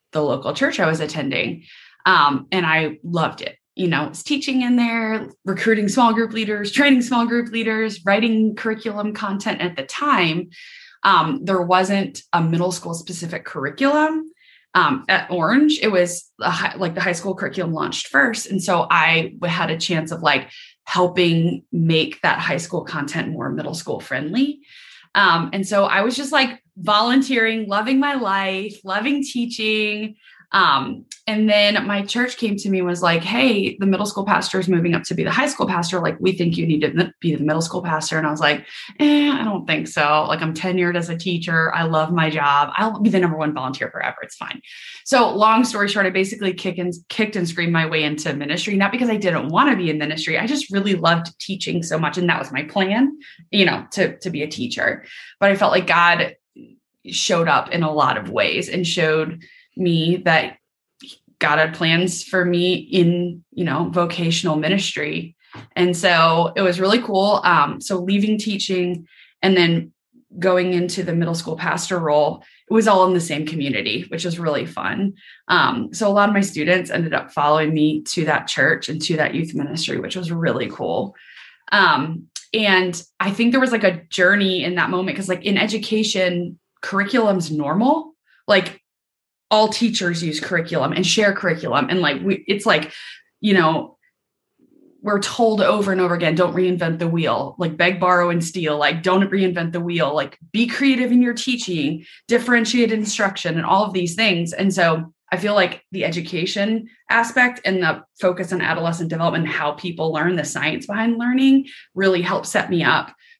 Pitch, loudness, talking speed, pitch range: 185 Hz, -19 LUFS, 190 wpm, 170-215 Hz